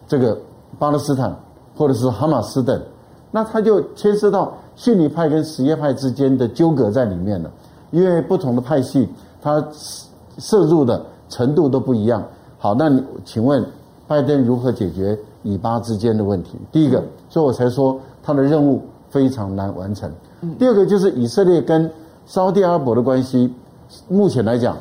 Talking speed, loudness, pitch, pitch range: 260 characters per minute, -18 LUFS, 135 Hz, 120-160 Hz